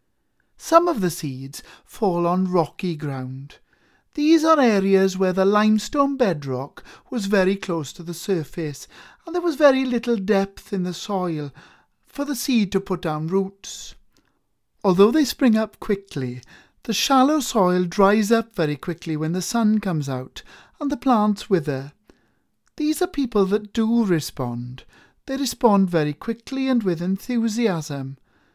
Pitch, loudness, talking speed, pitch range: 195 Hz, -21 LUFS, 150 wpm, 165-235 Hz